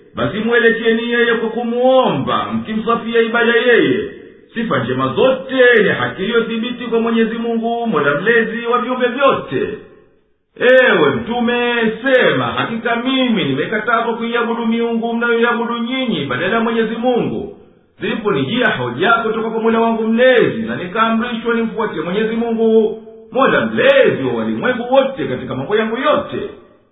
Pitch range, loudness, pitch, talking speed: 225-240 Hz, -15 LUFS, 230 Hz, 125 wpm